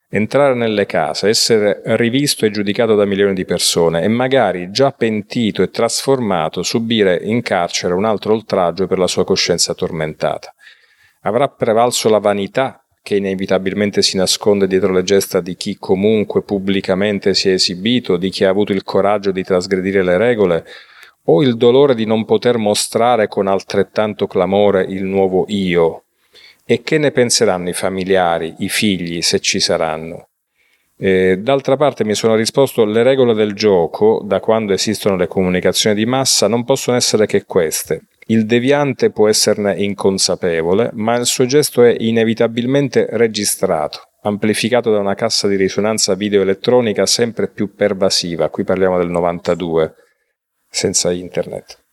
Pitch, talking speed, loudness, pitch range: 105 Hz, 150 wpm, -15 LUFS, 95-115 Hz